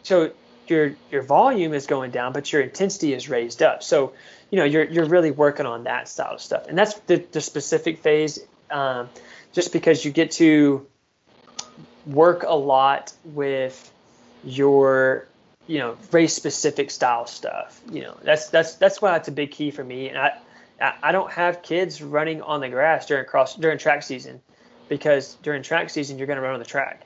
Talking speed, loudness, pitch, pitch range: 195 wpm, -21 LUFS, 150 Hz, 140-165 Hz